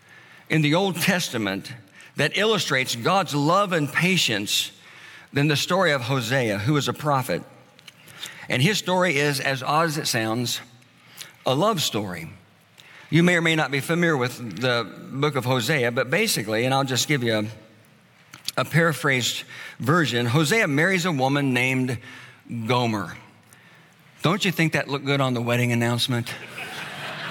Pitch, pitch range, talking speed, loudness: 140 Hz, 120-160 Hz, 155 wpm, -22 LUFS